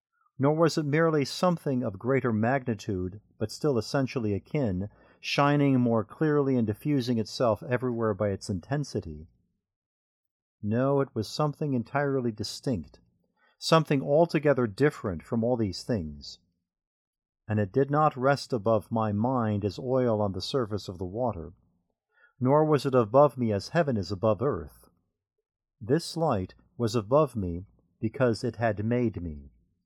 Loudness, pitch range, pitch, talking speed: -27 LUFS, 105-140 Hz, 120 Hz, 145 wpm